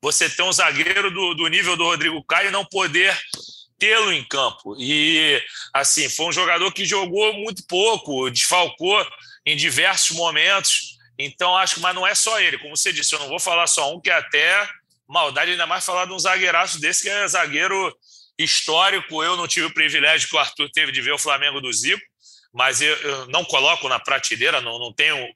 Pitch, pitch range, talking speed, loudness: 175 Hz, 150-190 Hz, 200 wpm, -18 LUFS